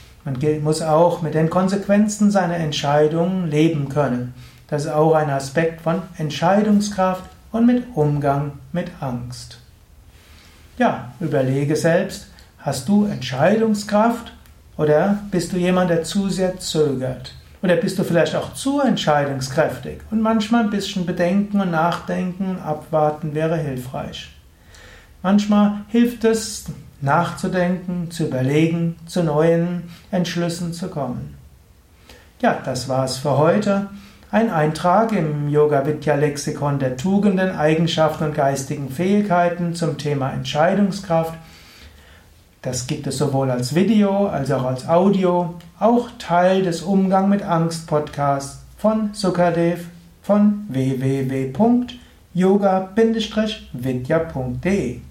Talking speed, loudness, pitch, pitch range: 110 wpm, -20 LUFS, 165 Hz, 140-190 Hz